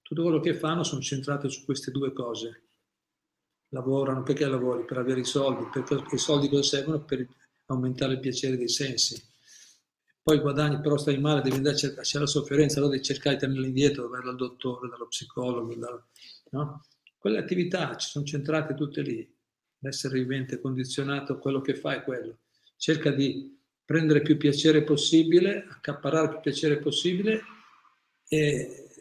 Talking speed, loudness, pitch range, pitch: 165 wpm, -27 LUFS, 130-150 Hz, 140 Hz